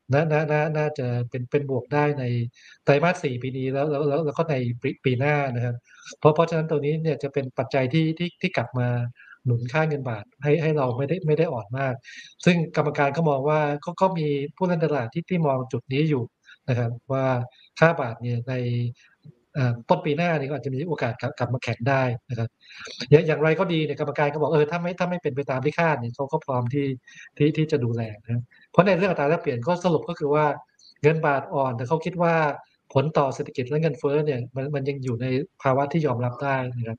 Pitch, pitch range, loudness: 145 Hz, 130-155 Hz, -24 LUFS